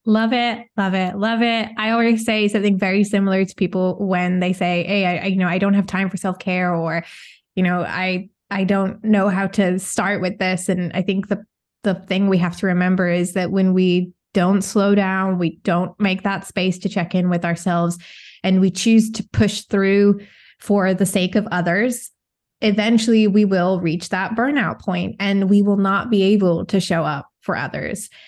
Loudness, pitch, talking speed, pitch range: -19 LUFS, 195 Hz, 205 wpm, 185-205 Hz